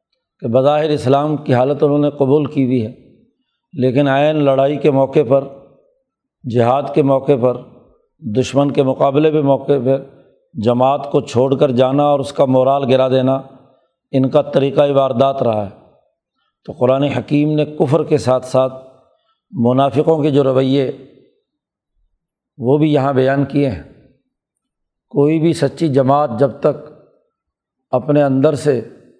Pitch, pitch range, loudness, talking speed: 140 Hz, 130-150 Hz, -15 LUFS, 145 wpm